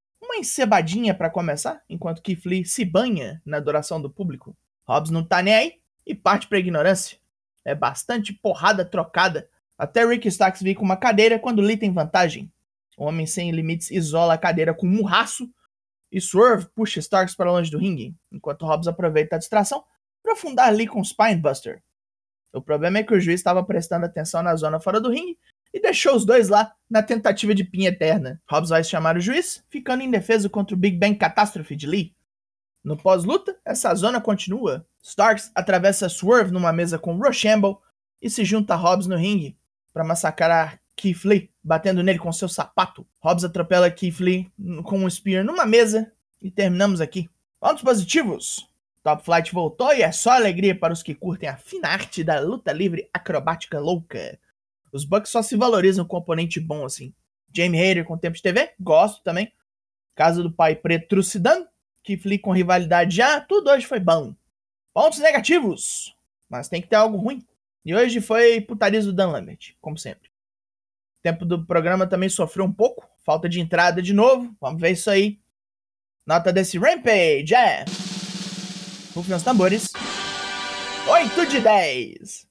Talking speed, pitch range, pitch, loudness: 175 wpm, 170-215 Hz, 190 Hz, -21 LUFS